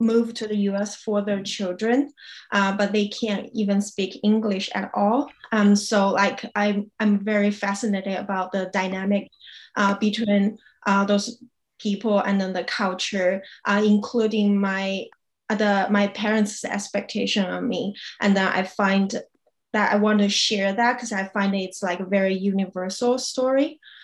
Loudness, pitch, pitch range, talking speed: -23 LUFS, 205 Hz, 195-215 Hz, 160 wpm